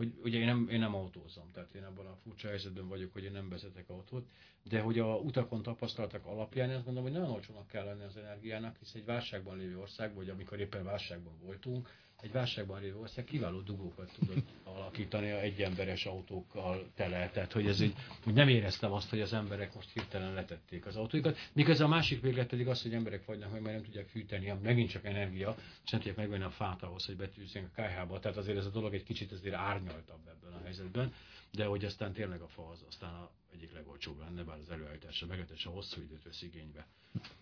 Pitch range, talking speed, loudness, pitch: 95-110 Hz, 215 wpm, -38 LUFS, 100 Hz